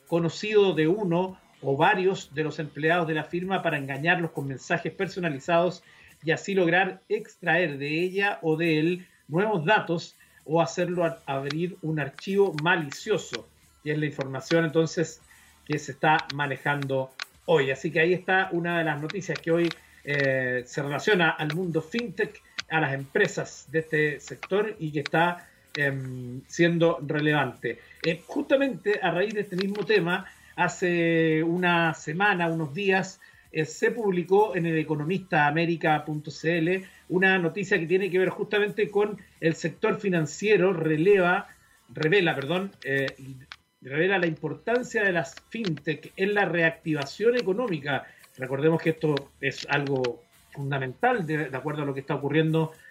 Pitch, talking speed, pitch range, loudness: 165 Hz, 145 wpm, 150-185 Hz, -26 LUFS